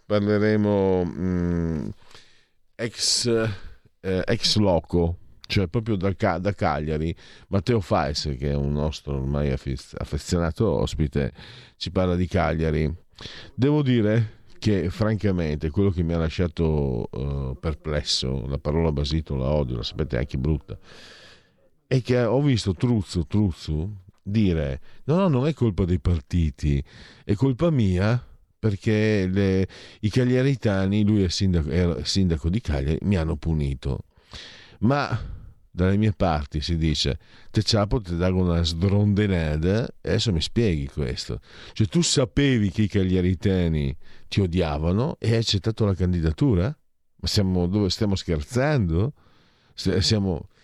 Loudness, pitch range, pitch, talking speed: -24 LUFS, 80-105 Hz, 95 Hz, 135 wpm